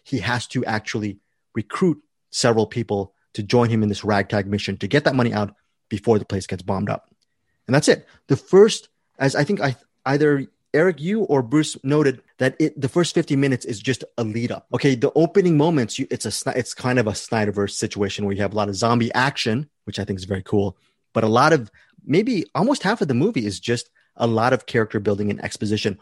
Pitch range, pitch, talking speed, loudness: 105-140 Hz, 120 Hz, 225 wpm, -21 LUFS